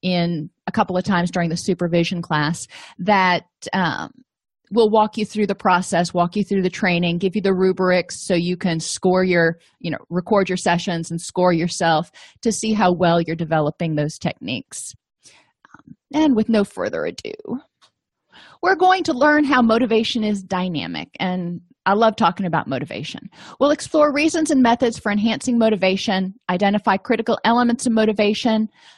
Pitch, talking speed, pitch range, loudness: 195 Hz, 165 wpm, 175-225 Hz, -19 LUFS